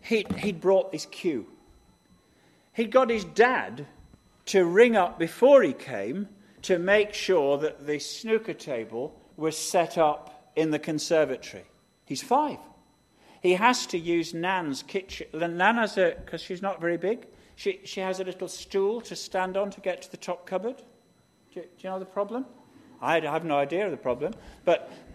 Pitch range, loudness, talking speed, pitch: 165-215 Hz, -27 LUFS, 175 wpm, 185 Hz